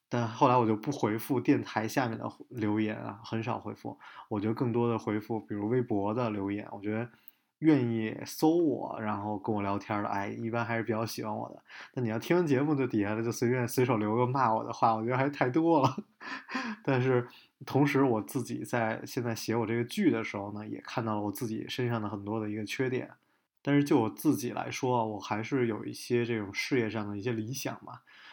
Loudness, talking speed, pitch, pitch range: -31 LUFS, 320 characters per minute, 115 Hz, 105-125 Hz